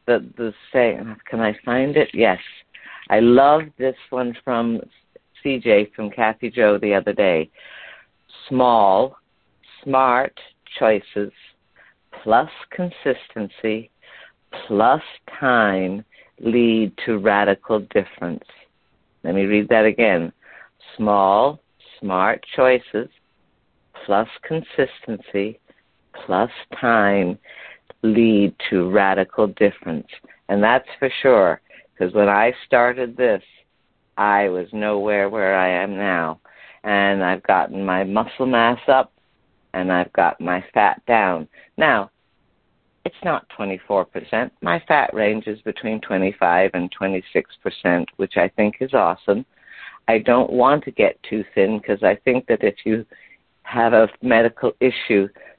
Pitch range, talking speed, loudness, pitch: 100-120 Hz, 120 wpm, -19 LUFS, 110 Hz